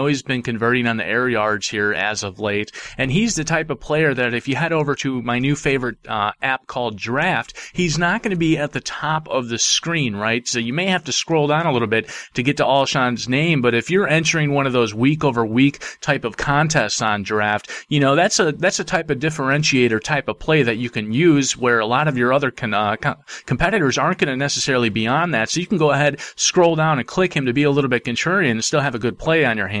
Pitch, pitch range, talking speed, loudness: 135 Hz, 120-155 Hz, 260 wpm, -19 LUFS